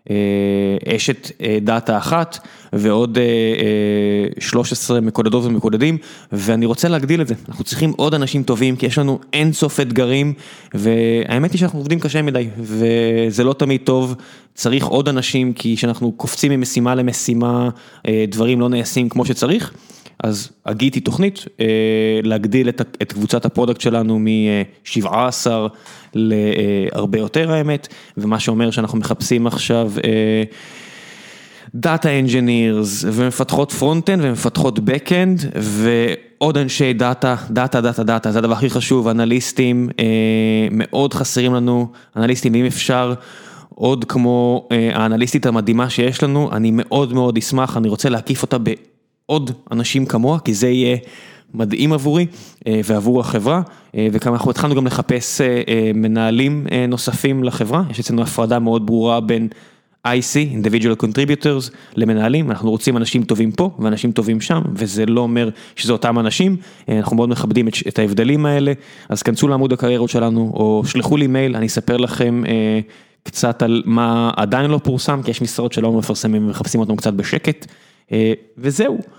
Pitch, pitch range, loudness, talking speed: 120 Hz, 115-135 Hz, -17 LUFS, 140 wpm